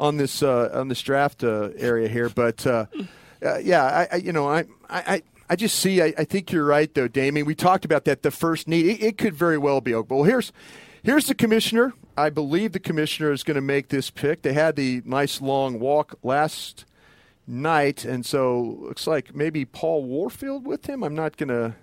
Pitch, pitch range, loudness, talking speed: 150 Hz, 135-170 Hz, -23 LUFS, 215 wpm